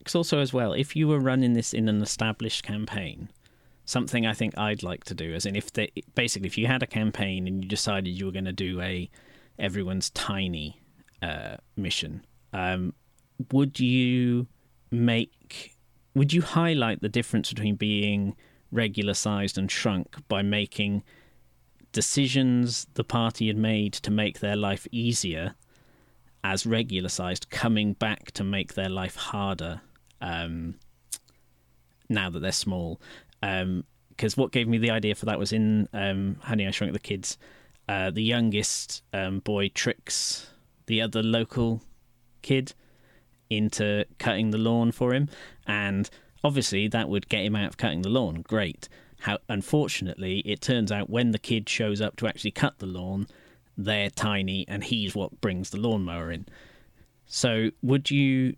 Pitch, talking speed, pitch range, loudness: 105 Hz, 160 wpm, 95-120 Hz, -27 LUFS